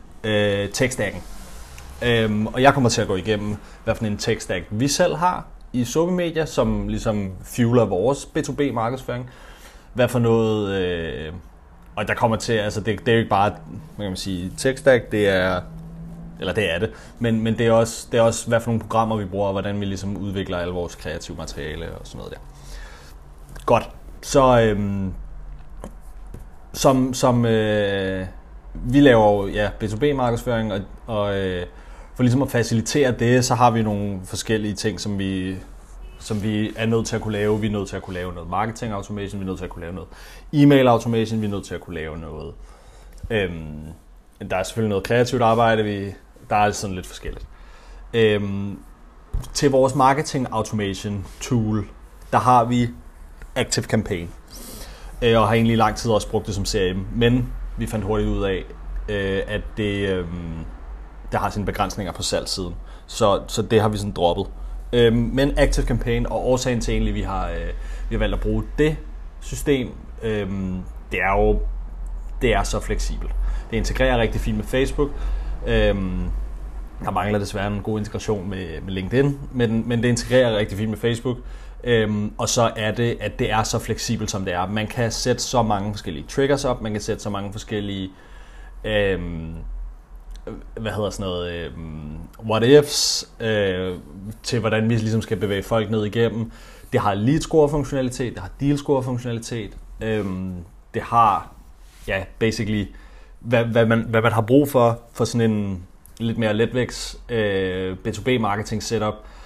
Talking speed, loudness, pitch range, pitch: 175 wpm, -22 LUFS, 95-115 Hz, 105 Hz